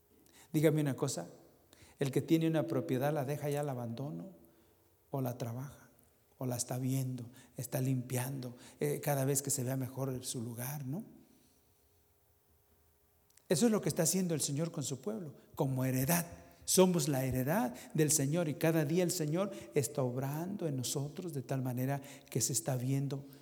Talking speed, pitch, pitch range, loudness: 170 wpm, 135 Hz, 125-155 Hz, -35 LUFS